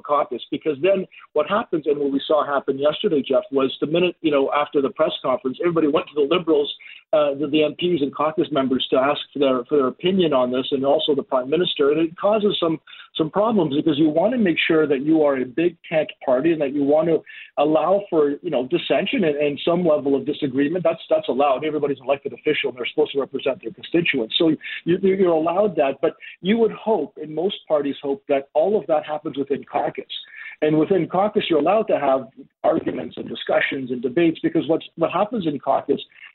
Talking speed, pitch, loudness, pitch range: 225 wpm, 155 Hz, -21 LUFS, 145-190 Hz